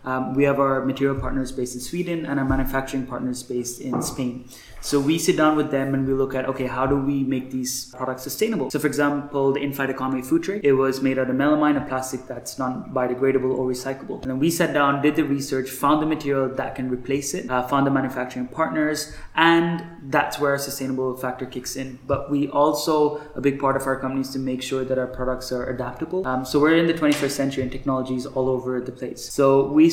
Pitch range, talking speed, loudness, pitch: 130-145 Hz, 235 wpm, -23 LUFS, 135 Hz